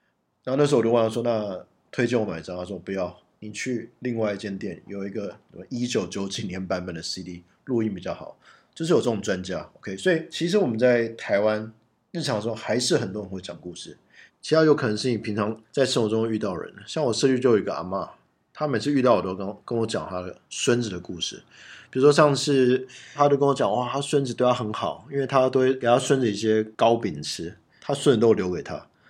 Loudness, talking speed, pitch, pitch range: -24 LUFS, 335 characters per minute, 115 Hz, 105-130 Hz